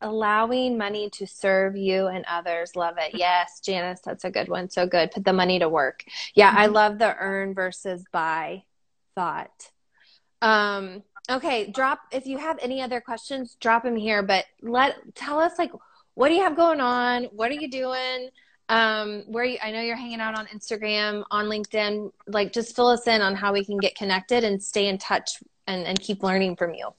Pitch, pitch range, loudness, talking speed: 210 Hz, 190-245 Hz, -24 LUFS, 200 wpm